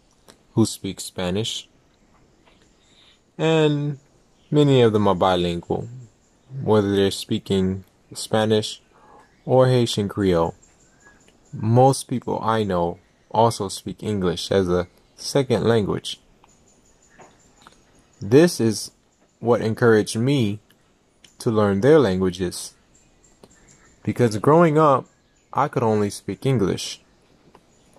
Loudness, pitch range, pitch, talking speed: -21 LUFS, 95-125 Hz, 110 Hz, 95 wpm